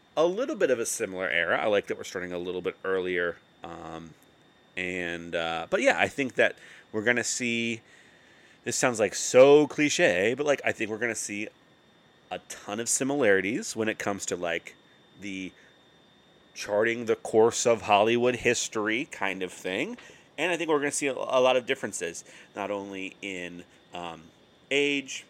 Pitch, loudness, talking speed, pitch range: 110 Hz, -26 LUFS, 175 wpm, 90-135 Hz